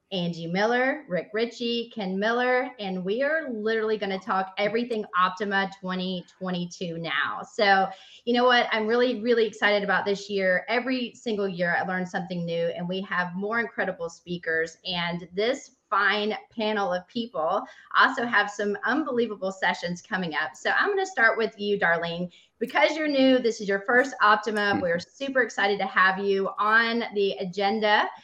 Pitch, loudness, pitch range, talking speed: 205 Hz, -25 LUFS, 185-230 Hz, 170 wpm